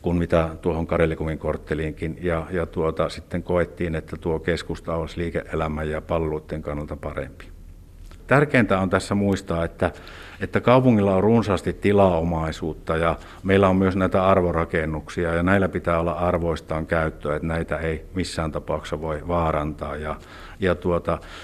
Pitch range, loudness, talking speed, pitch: 80-90 Hz, -23 LUFS, 145 wpm, 85 Hz